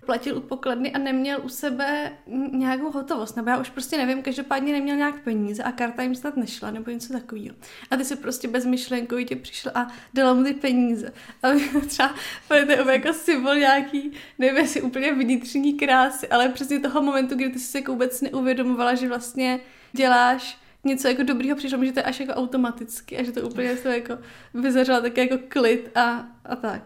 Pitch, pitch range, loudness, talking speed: 260 Hz, 245-275 Hz, -23 LUFS, 190 wpm